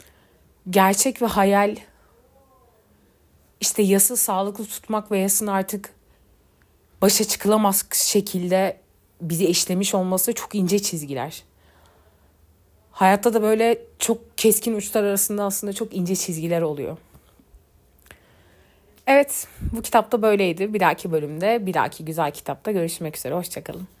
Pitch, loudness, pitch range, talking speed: 195 Hz, -21 LUFS, 165-215 Hz, 110 wpm